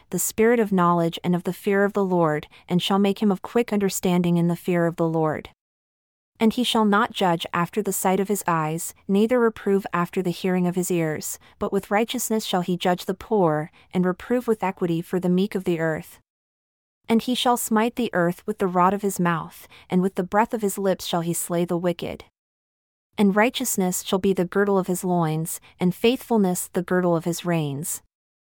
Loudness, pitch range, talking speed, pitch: -23 LUFS, 175-205 Hz, 215 wpm, 185 Hz